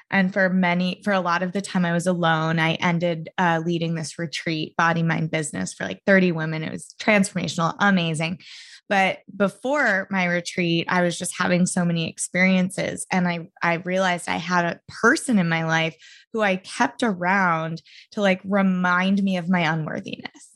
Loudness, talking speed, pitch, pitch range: -22 LUFS, 180 wpm, 180 Hz, 165-195 Hz